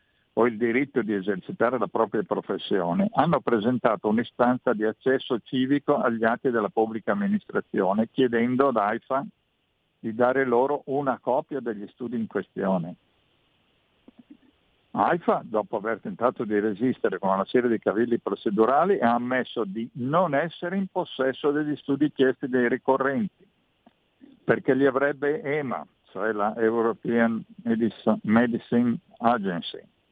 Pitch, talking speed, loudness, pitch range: 125 Hz, 130 wpm, -25 LUFS, 115-140 Hz